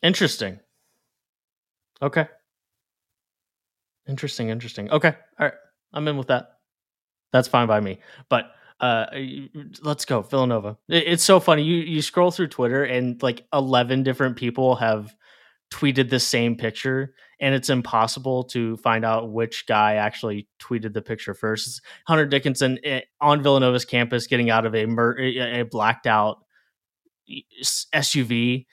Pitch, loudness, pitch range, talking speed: 125 Hz, -22 LUFS, 110-140 Hz, 135 wpm